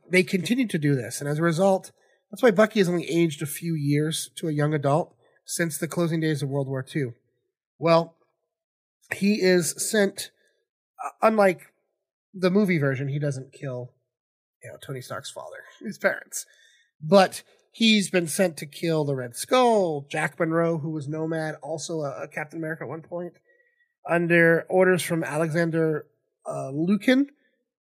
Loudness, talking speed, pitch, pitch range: -24 LUFS, 160 wpm, 165 Hz, 155-195 Hz